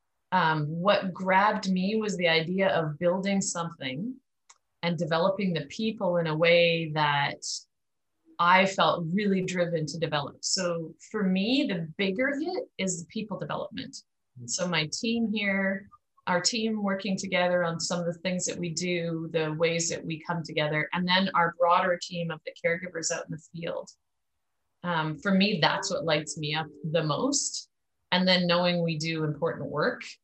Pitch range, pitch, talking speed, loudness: 160-195 Hz, 175 Hz, 165 wpm, -27 LUFS